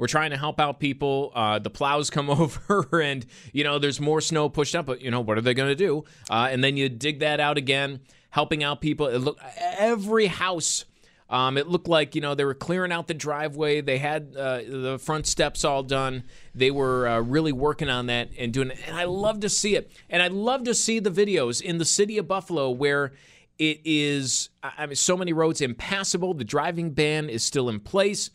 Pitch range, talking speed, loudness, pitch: 135-170 Hz, 225 wpm, -25 LUFS, 150 Hz